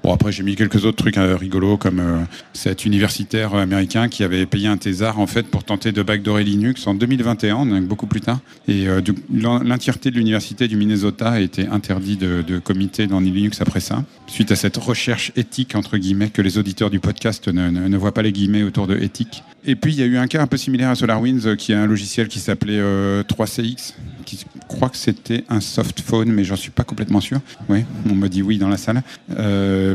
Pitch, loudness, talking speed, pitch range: 105 Hz, -19 LUFS, 230 wpm, 100-115 Hz